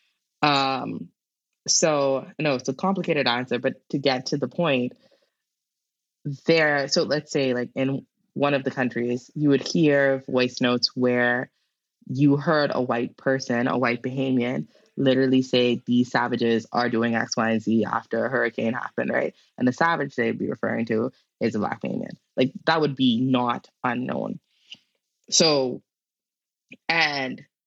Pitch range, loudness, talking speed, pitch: 120-145 Hz, -23 LUFS, 155 wpm, 130 Hz